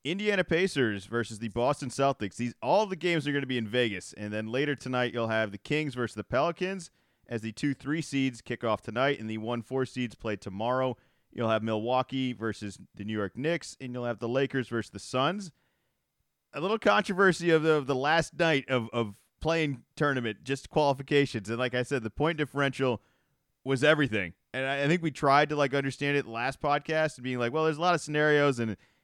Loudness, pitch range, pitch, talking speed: -29 LUFS, 115-150 Hz, 130 Hz, 215 wpm